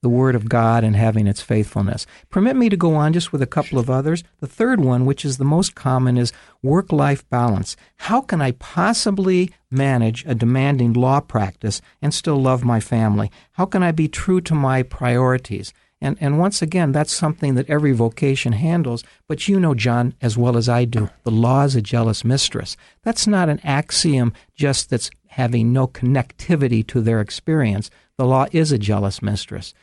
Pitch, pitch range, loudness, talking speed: 130 Hz, 115-155 Hz, -19 LUFS, 190 wpm